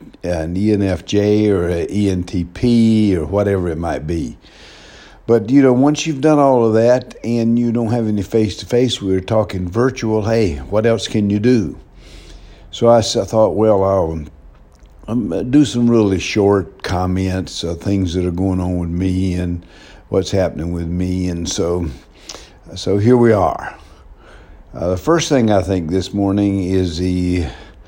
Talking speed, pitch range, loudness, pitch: 160 wpm, 90-115 Hz, -16 LUFS, 100 Hz